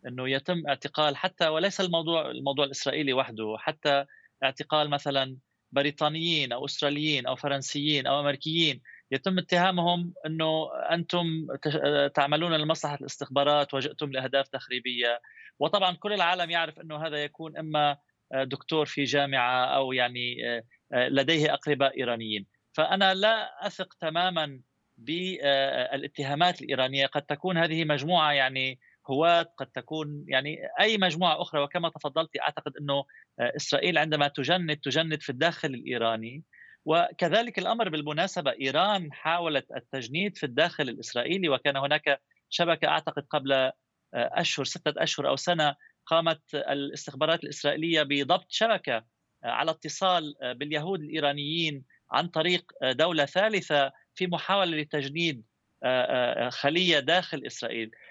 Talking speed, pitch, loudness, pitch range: 115 wpm, 150 Hz, -27 LUFS, 140-165 Hz